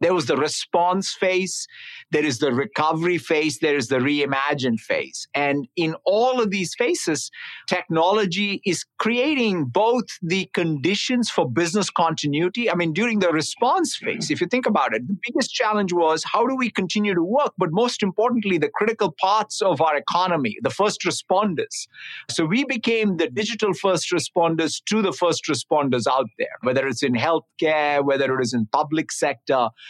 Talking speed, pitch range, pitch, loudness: 175 wpm, 155-215 Hz, 180 Hz, -22 LUFS